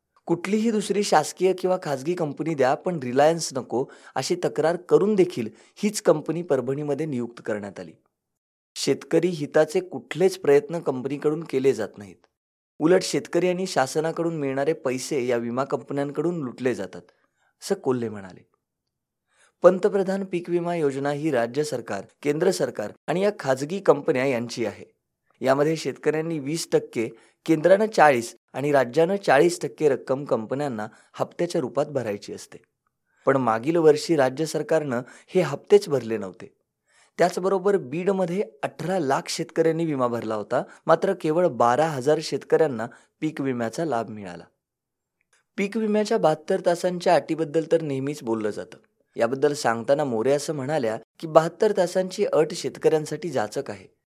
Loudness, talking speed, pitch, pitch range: -24 LUFS, 135 wpm, 155 Hz, 130-175 Hz